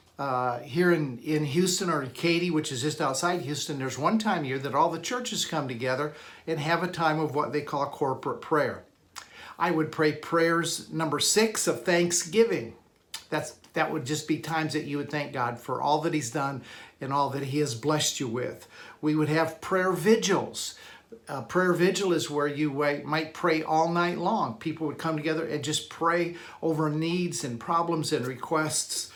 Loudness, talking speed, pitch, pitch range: -27 LUFS, 200 wpm, 155 Hz, 145-170 Hz